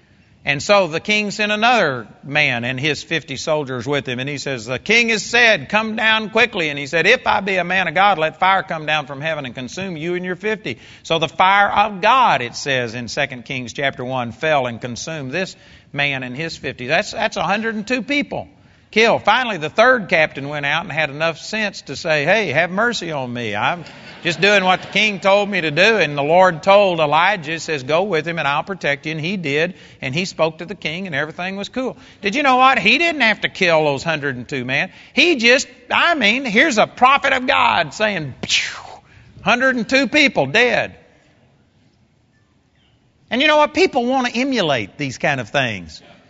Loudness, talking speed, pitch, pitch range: -17 LUFS, 210 wpm, 175 Hz, 145-215 Hz